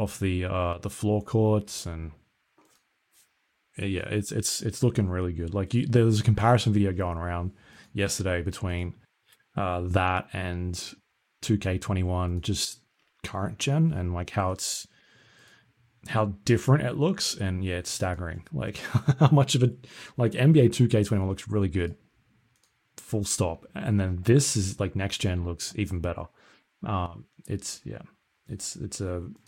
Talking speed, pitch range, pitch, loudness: 150 wpm, 90-115 Hz, 100 Hz, -27 LUFS